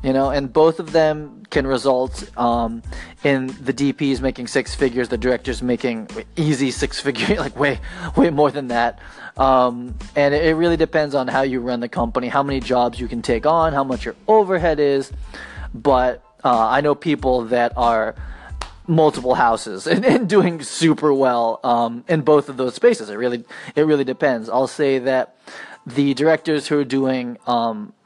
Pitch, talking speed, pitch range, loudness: 135 Hz, 180 wpm, 125-150 Hz, -19 LUFS